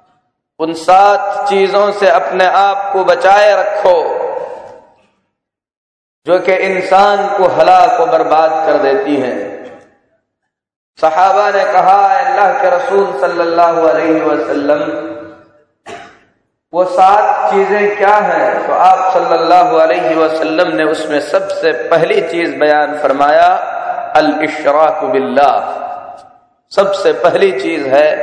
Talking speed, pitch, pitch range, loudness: 105 wpm, 190 Hz, 160-205 Hz, -11 LUFS